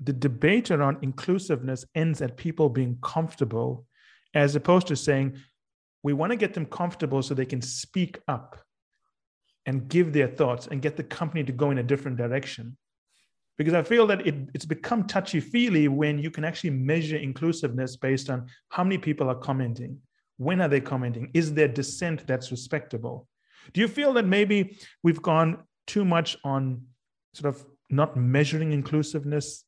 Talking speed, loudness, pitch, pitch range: 170 wpm, -26 LUFS, 150 Hz, 135-165 Hz